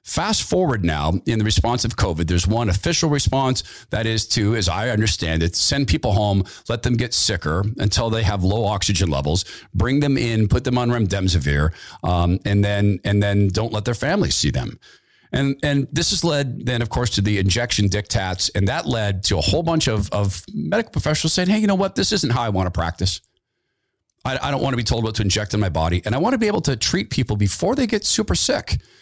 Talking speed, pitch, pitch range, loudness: 230 wpm, 110 Hz, 95-130 Hz, -20 LUFS